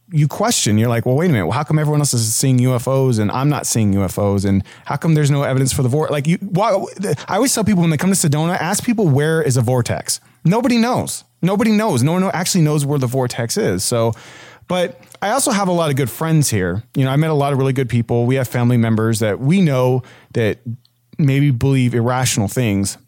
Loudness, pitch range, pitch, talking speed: -17 LUFS, 120-160 Hz, 135 Hz, 240 wpm